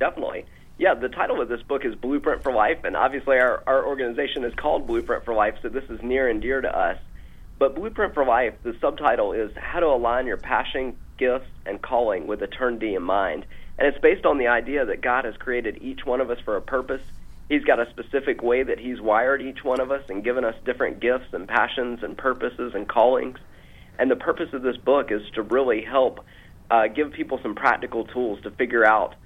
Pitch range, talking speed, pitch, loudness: 115-150 Hz, 225 wpm, 130 Hz, -23 LUFS